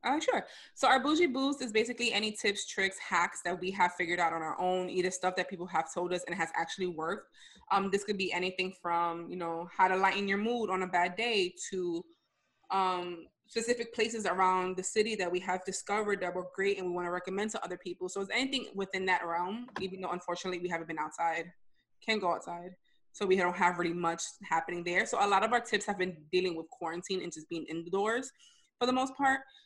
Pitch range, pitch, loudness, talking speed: 175-210 Hz, 185 Hz, -32 LUFS, 230 wpm